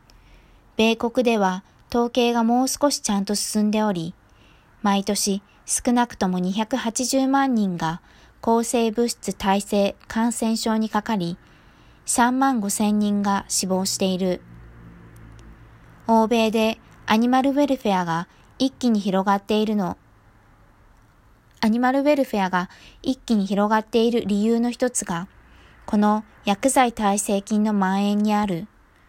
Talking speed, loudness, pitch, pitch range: 235 characters per minute, -22 LUFS, 210 Hz, 190-235 Hz